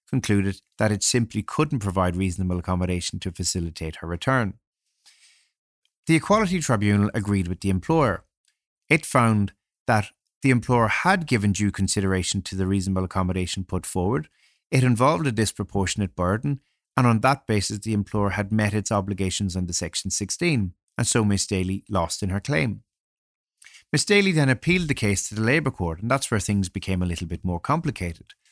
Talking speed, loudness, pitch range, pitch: 170 wpm, -24 LUFS, 95-125 Hz, 100 Hz